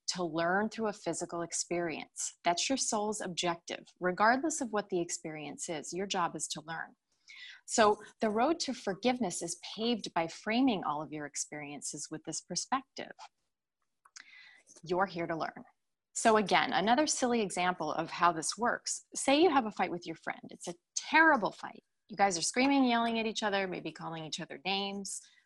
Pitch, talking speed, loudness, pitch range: 190 Hz, 175 wpm, -32 LUFS, 170-230 Hz